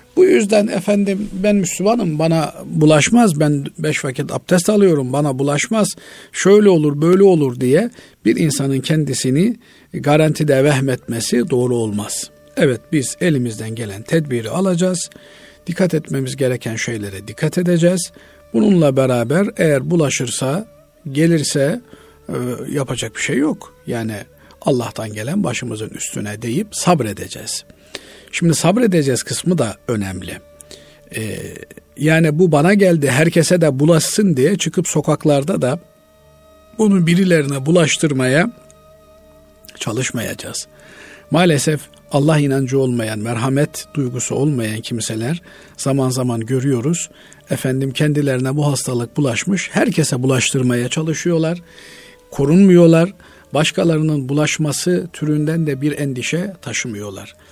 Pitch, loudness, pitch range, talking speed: 150 Hz, -16 LUFS, 130-175 Hz, 105 wpm